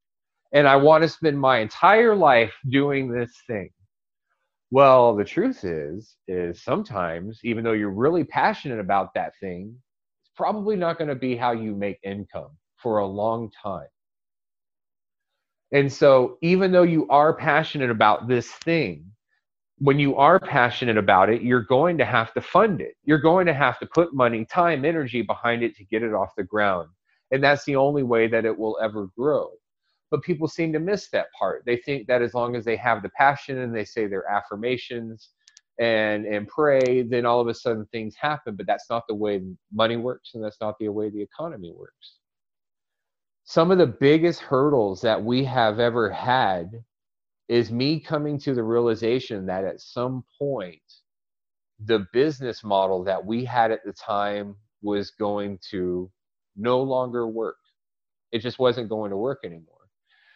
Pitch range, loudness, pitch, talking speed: 105-140 Hz, -22 LUFS, 120 Hz, 175 wpm